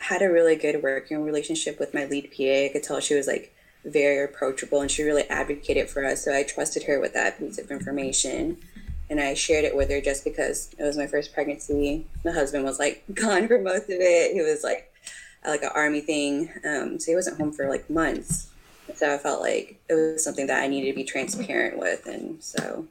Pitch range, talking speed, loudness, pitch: 140-165 Hz, 225 wpm, -25 LUFS, 145 Hz